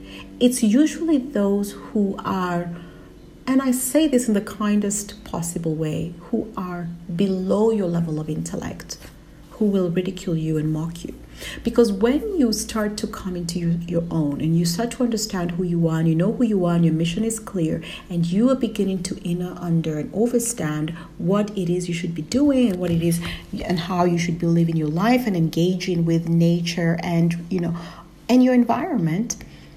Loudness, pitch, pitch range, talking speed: -22 LUFS, 180 Hz, 170-220 Hz, 190 wpm